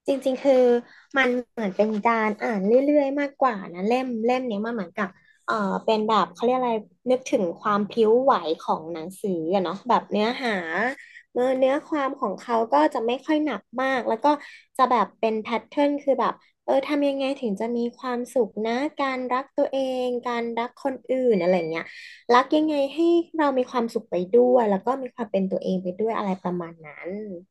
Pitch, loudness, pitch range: 245 Hz, -24 LUFS, 210-265 Hz